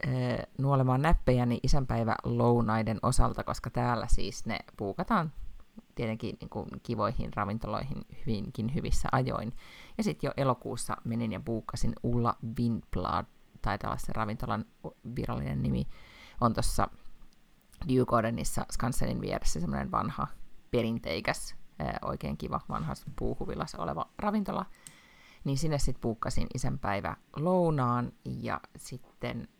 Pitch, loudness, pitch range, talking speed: 120 Hz, -32 LUFS, 115-140 Hz, 110 wpm